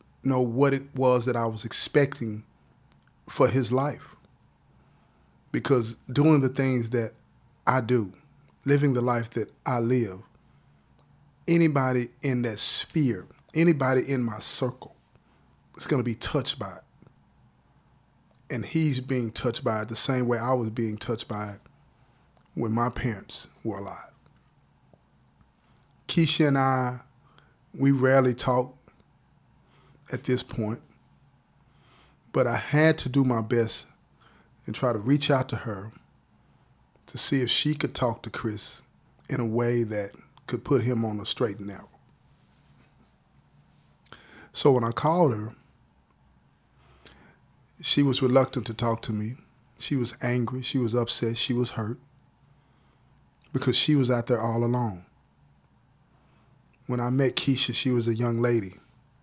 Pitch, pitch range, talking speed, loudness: 125 Hz, 115-135 Hz, 140 wpm, -26 LUFS